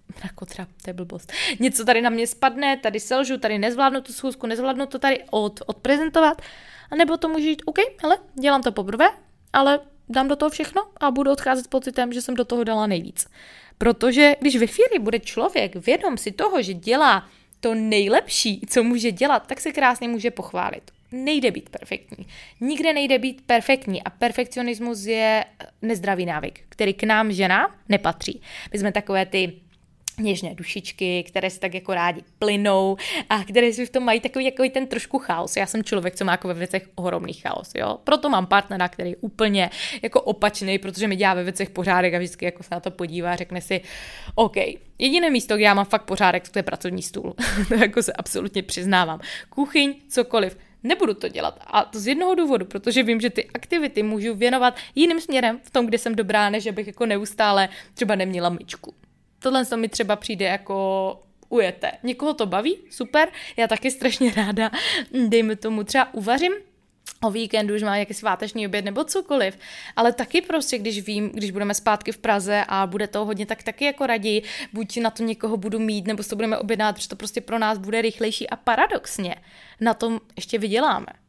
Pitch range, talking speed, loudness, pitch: 200-260 Hz, 190 wpm, -22 LUFS, 225 Hz